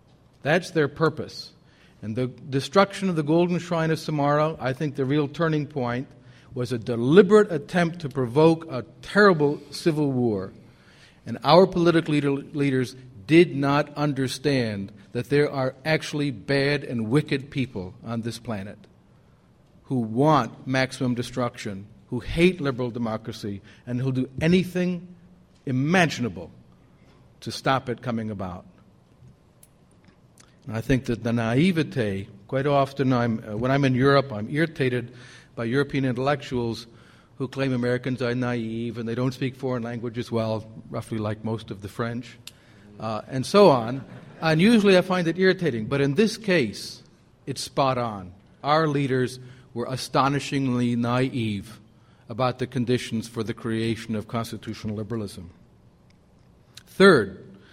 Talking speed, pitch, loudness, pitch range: 135 wpm, 130 Hz, -24 LUFS, 115-145 Hz